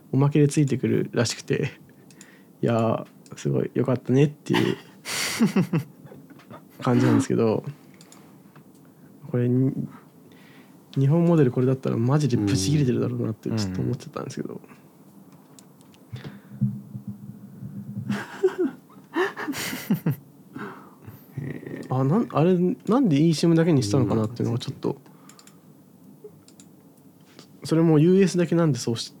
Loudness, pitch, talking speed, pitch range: -23 LUFS, 145 Hz, 255 characters per minute, 120-170 Hz